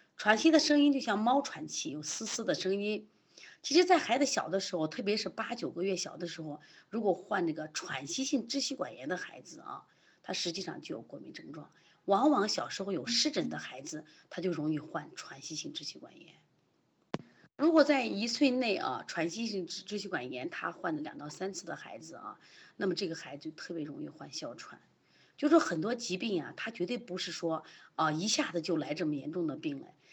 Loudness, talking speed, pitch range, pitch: -33 LUFS, 300 characters per minute, 170-275 Hz, 205 Hz